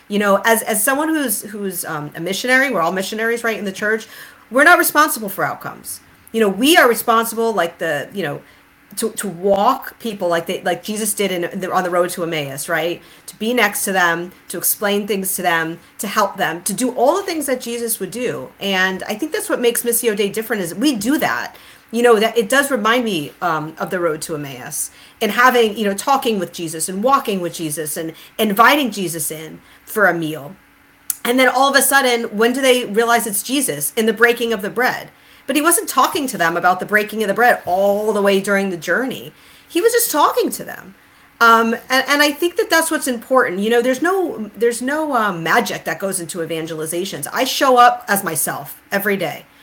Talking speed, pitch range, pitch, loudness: 220 wpm, 180-250 Hz, 220 Hz, -17 LUFS